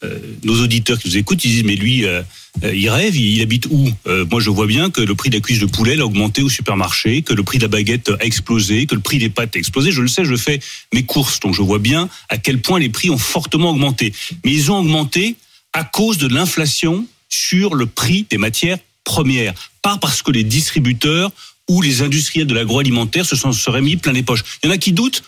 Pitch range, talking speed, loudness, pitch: 110-155 Hz, 250 wpm, -15 LUFS, 125 Hz